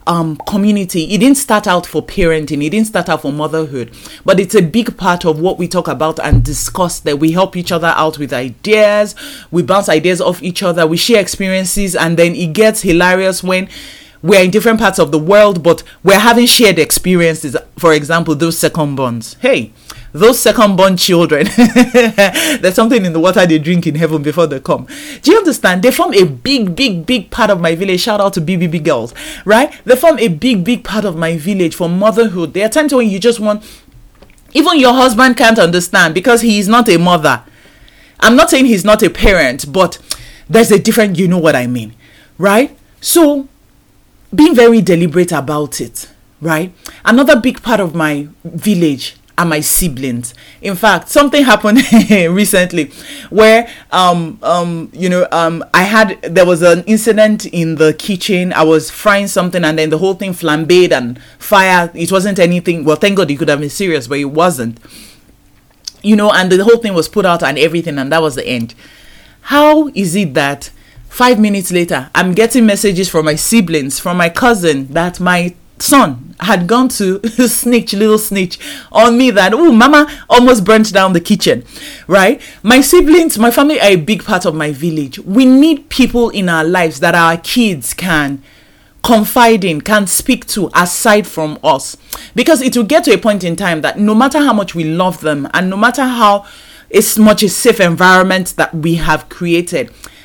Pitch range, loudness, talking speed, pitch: 165-220 Hz, -11 LUFS, 190 wpm, 185 Hz